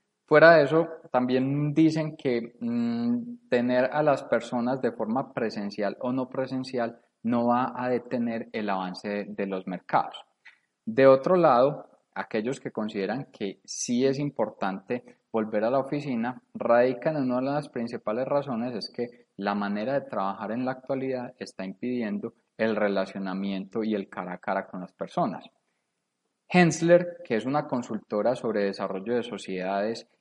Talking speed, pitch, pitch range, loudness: 155 wpm, 125 Hz, 105-145 Hz, -27 LUFS